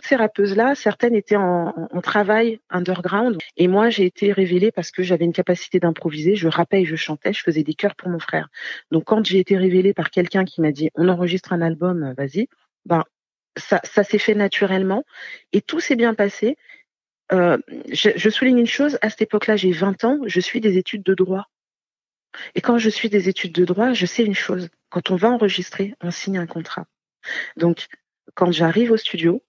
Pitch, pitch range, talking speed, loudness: 190 Hz, 180-220 Hz, 200 wpm, -20 LUFS